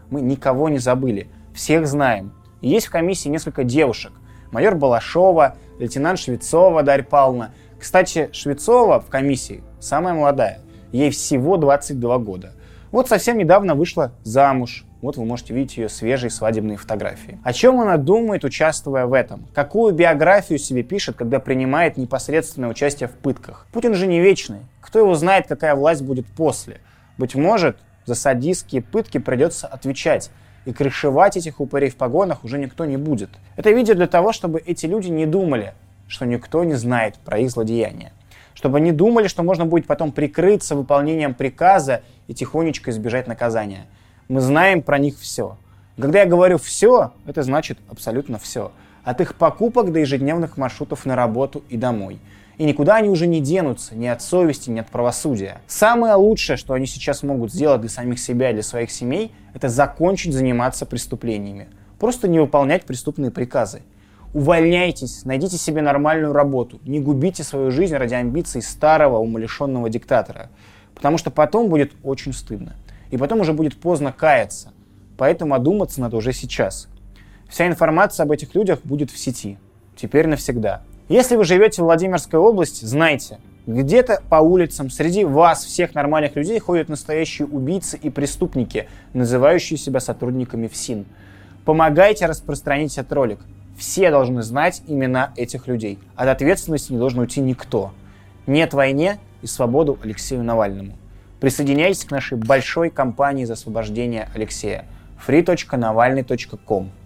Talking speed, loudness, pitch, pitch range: 150 wpm, -18 LUFS, 135 Hz, 115-160 Hz